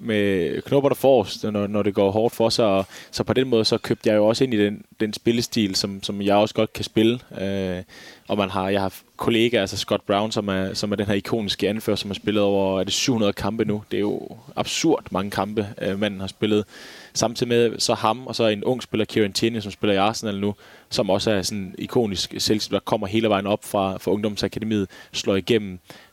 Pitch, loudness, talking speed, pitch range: 105 Hz, -22 LUFS, 230 wpm, 100-110 Hz